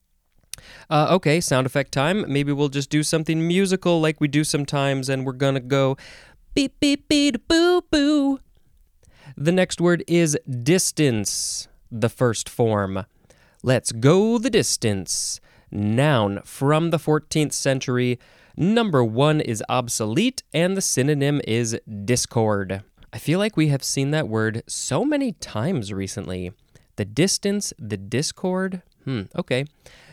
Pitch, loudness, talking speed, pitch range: 140 Hz, -22 LUFS, 135 wpm, 115-170 Hz